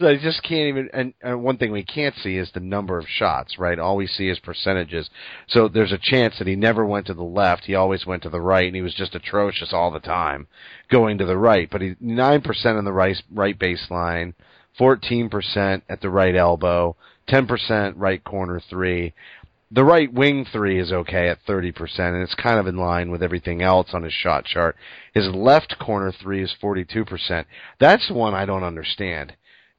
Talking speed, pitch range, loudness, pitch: 210 wpm, 90-110 Hz, -21 LUFS, 95 Hz